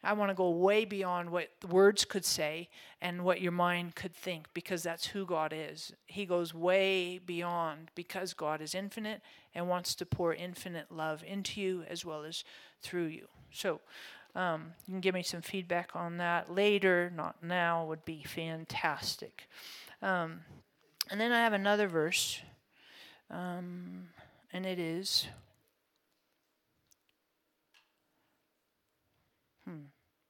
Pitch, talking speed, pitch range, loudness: 175 Hz, 140 wpm, 165-190 Hz, -34 LUFS